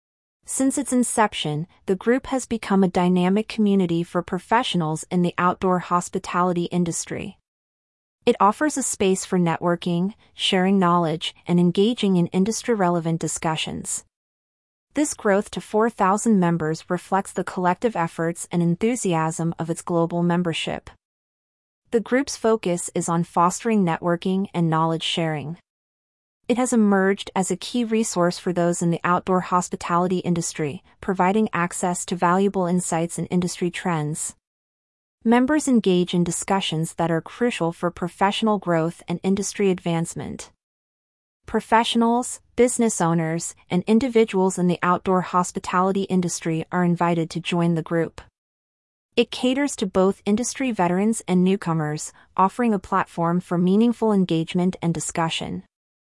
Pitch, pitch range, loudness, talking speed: 180 Hz, 170-205 Hz, -22 LUFS, 130 wpm